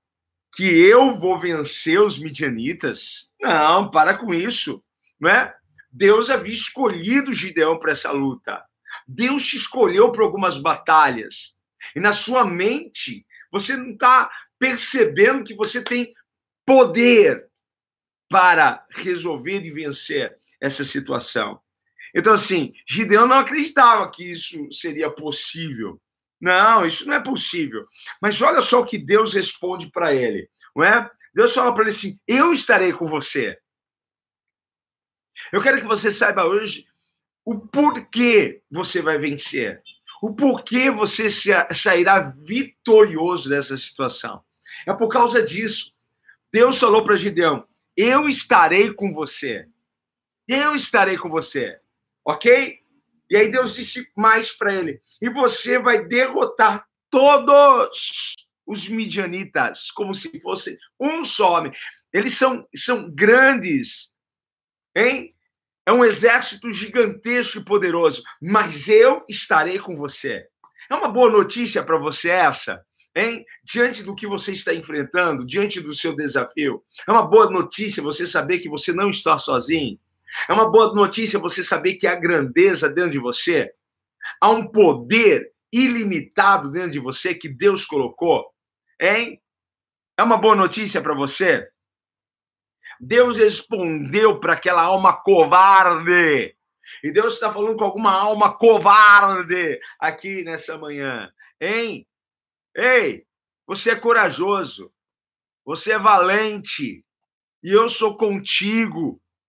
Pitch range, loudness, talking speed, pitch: 180-255 Hz, -18 LUFS, 130 wpm, 215 Hz